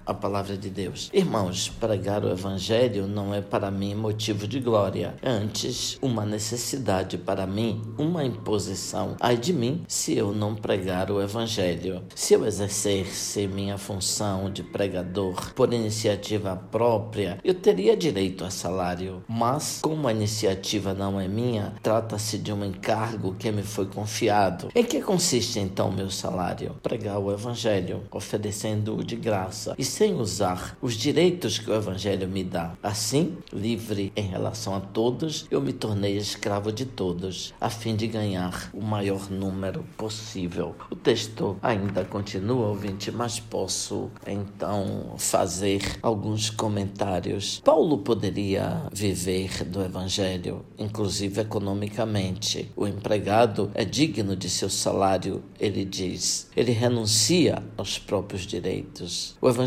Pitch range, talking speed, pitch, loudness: 95-115 Hz, 140 wpm, 105 Hz, -26 LUFS